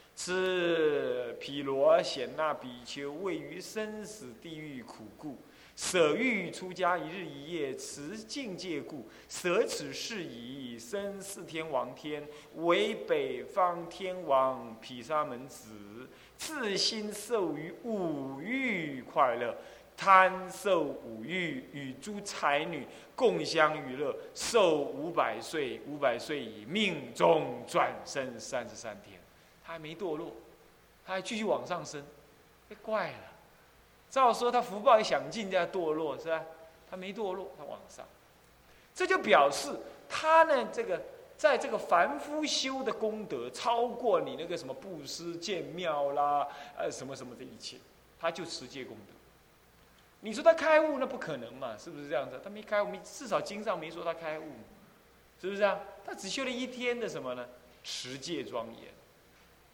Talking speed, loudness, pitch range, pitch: 205 characters per minute, -32 LUFS, 150-225 Hz, 185 Hz